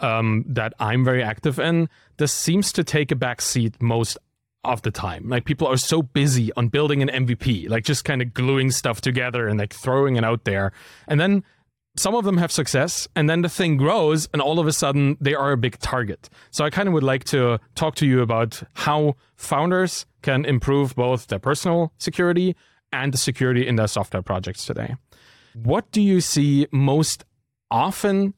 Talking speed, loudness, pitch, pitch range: 200 wpm, -21 LUFS, 135 Hz, 120-155 Hz